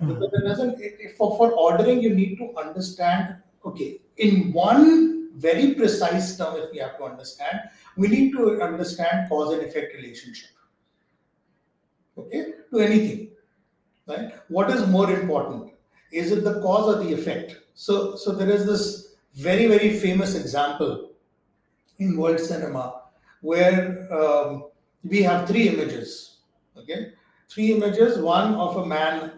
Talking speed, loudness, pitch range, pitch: 135 wpm, -22 LUFS, 170-220 Hz, 195 Hz